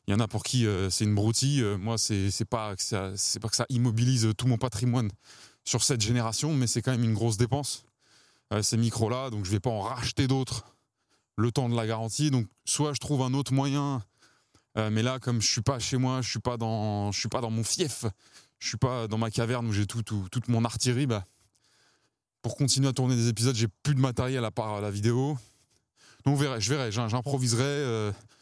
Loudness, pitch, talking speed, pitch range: -28 LUFS, 120 Hz, 225 wpm, 110-130 Hz